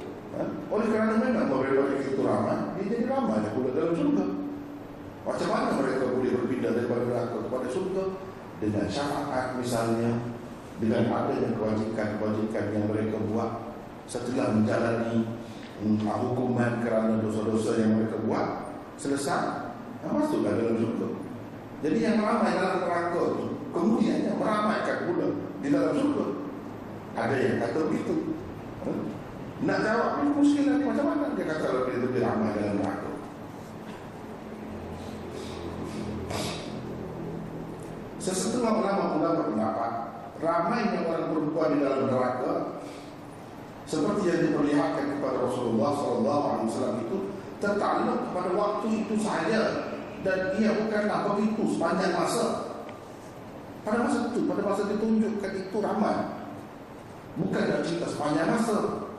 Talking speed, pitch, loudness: 125 wpm, 135 Hz, -28 LUFS